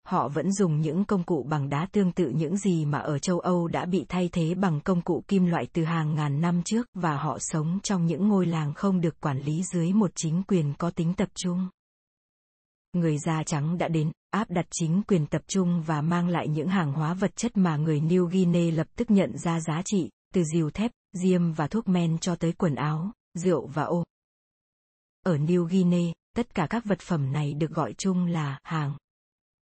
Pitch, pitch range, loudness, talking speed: 175 Hz, 160-185 Hz, -27 LUFS, 215 wpm